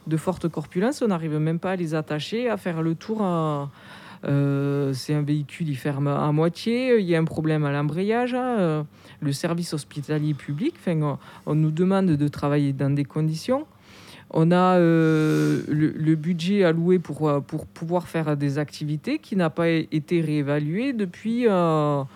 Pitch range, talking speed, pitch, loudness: 150-180 Hz, 180 wpm, 160 Hz, -24 LUFS